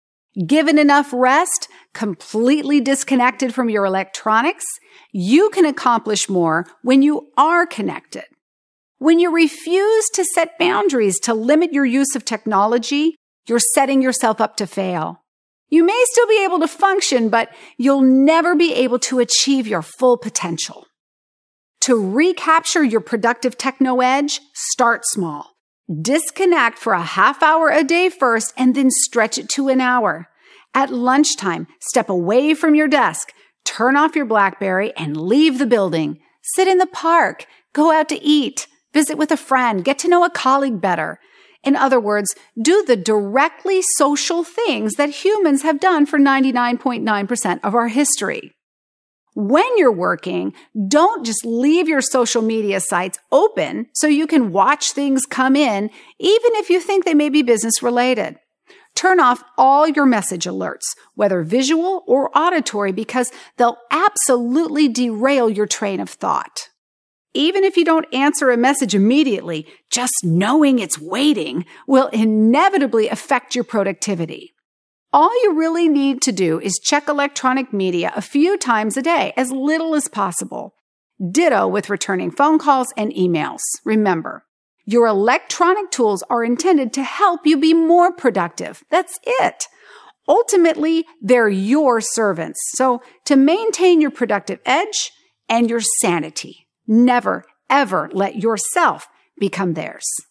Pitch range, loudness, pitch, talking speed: 225-320 Hz, -16 LUFS, 265 Hz, 145 wpm